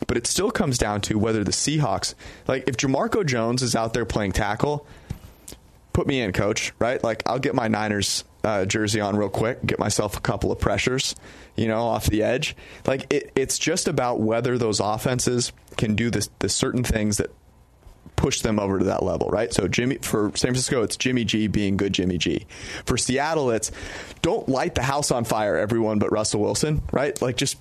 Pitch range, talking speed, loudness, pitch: 105-125 Hz, 205 wpm, -23 LUFS, 110 Hz